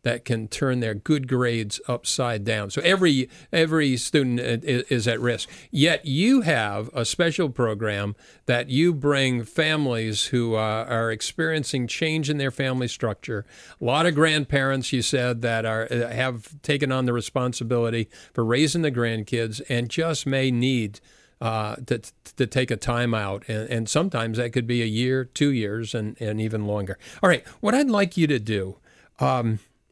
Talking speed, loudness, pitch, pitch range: 175 wpm, -24 LUFS, 125 Hz, 115-145 Hz